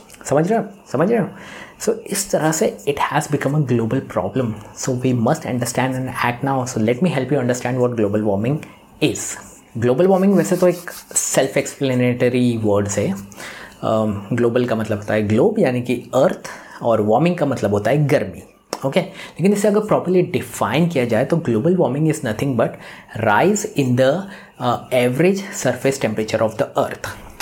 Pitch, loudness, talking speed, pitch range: 125 Hz, -19 LUFS, 185 wpm, 110-150 Hz